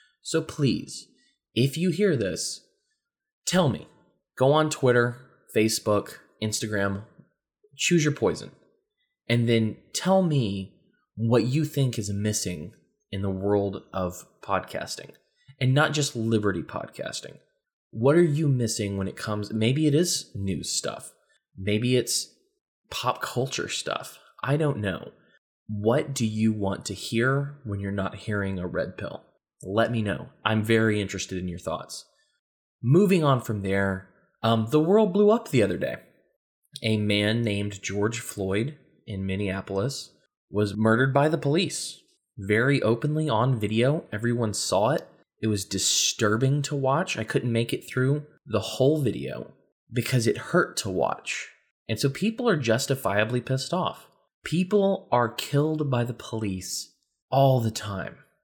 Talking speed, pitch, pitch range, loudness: 145 wpm, 120 Hz, 105-150 Hz, -26 LUFS